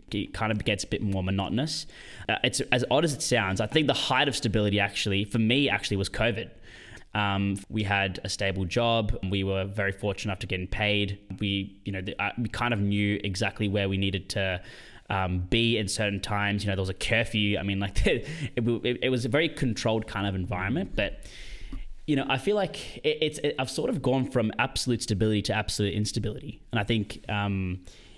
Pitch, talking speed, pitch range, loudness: 105 Hz, 220 wpm, 100-120 Hz, -28 LUFS